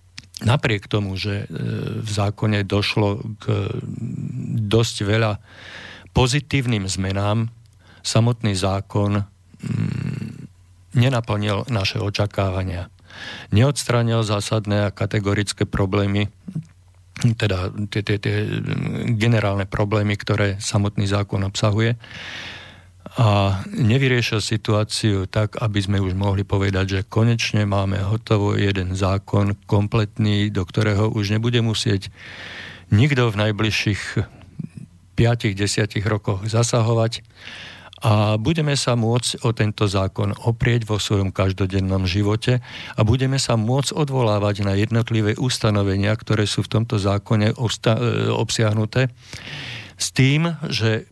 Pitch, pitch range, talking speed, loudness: 105 Hz, 100-115 Hz, 100 wpm, -21 LUFS